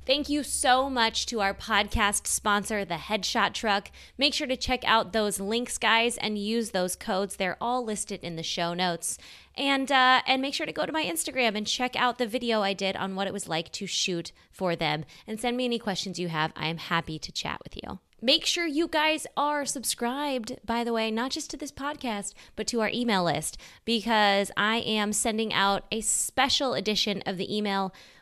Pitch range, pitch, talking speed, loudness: 195-255 Hz, 220 Hz, 215 wpm, -27 LUFS